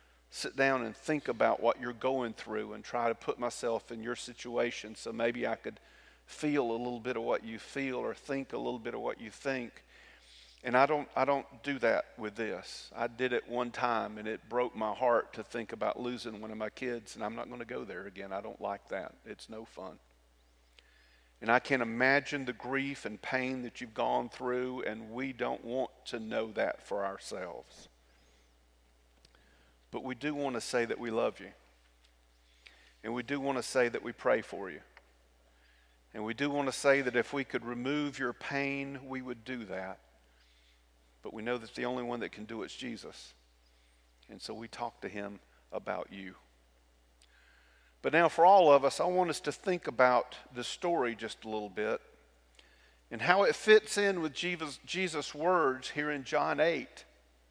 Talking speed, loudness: 200 wpm, -33 LUFS